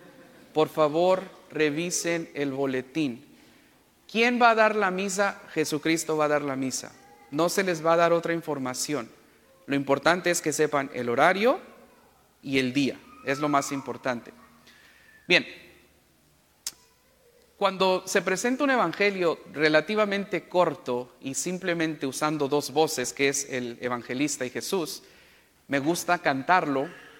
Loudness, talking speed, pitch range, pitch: -26 LUFS, 135 wpm, 140-180 Hz, 155 Hz